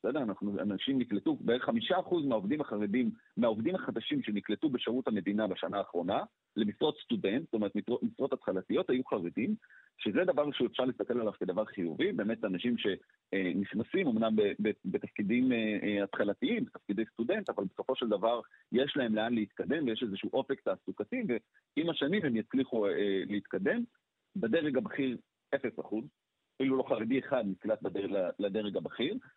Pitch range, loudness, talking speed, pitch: 105-145 Hz, -33 LUFS, 135 wpm, 115 Hz